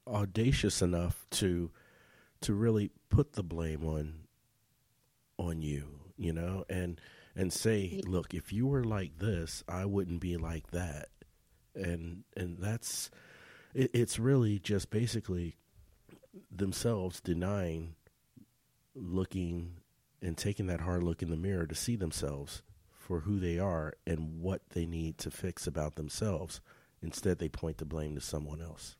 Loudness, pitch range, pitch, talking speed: -36 LUFS, 80-105 Hz, 90 Hz, 145 wpm